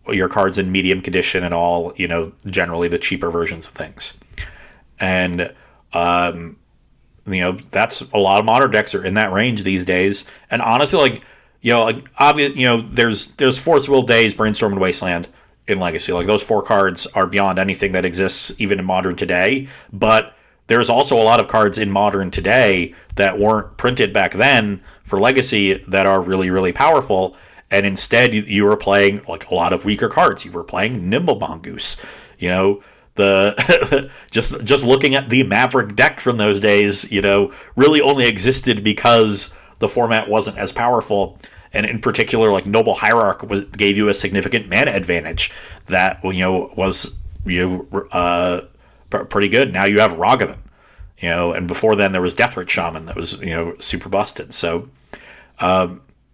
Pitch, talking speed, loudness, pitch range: 100 Hz, 180 wpm, -16 LUFS, 90-110 Hz